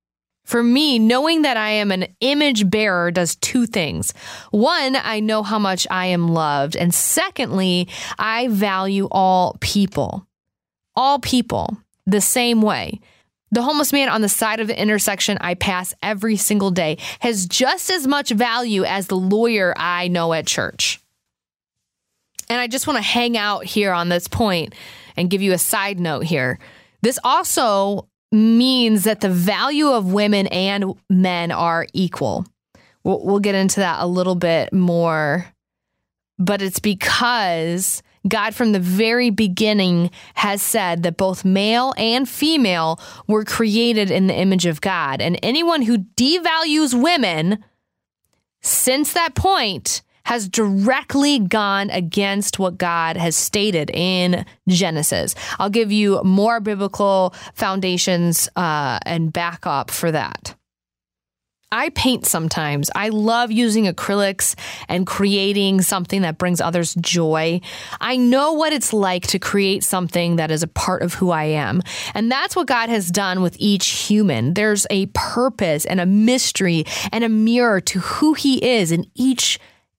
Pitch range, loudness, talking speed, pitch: 180-230 Hz, -18 LUFS, 150 wpm, 200 Hz